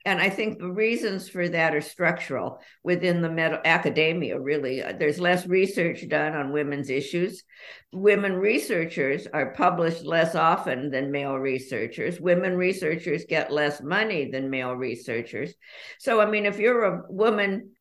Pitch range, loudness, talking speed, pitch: 150-190 Hz, -25 LUFS, 150 wpm, 170 Hz